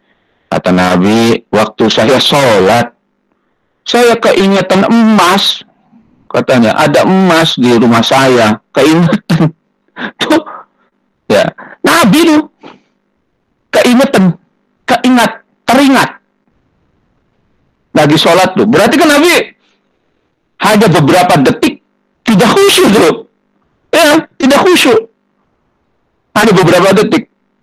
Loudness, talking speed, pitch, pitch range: -8 LUFS, 85 wpm, 220 Hz, 180-265 Hz